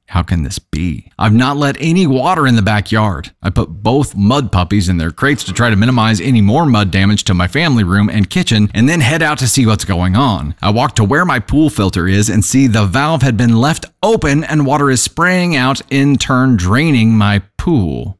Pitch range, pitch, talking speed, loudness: 100-140 Hz, 115 Hz, 225 wpm, -12 LUFS